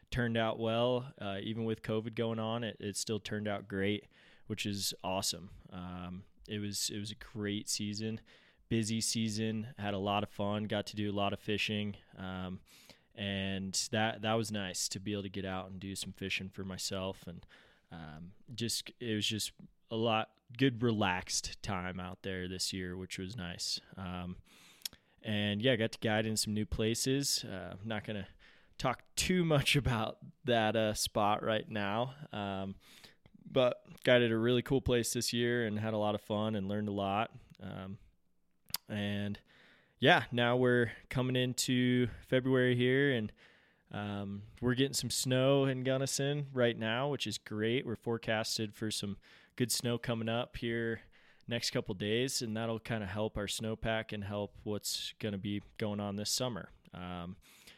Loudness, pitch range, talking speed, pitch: -35 LUFS, 100-120 Hz, 180 wpm, 110 Hz